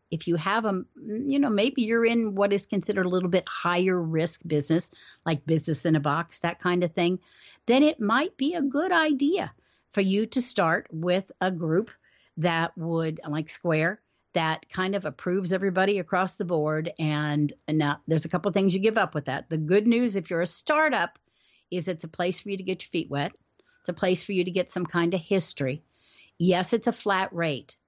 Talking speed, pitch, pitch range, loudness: 215 wpm, 180 Hz, 165-200 Hz, -26 LUFS